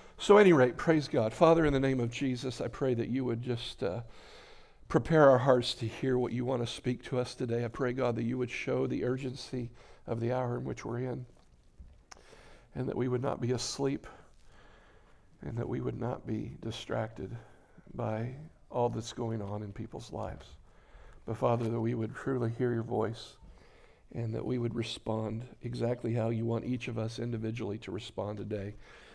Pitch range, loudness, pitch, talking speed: 115-125 Hz, -32 LUFS, 120 Hz, 195 wpm